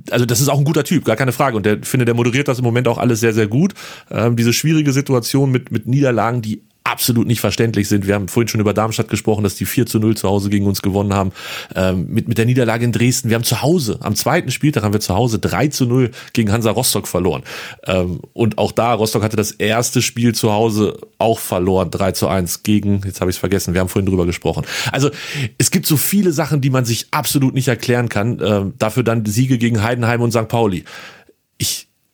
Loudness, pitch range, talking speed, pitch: -17 LUFS, 105-125 Hz, 240 wpm, 115 Hz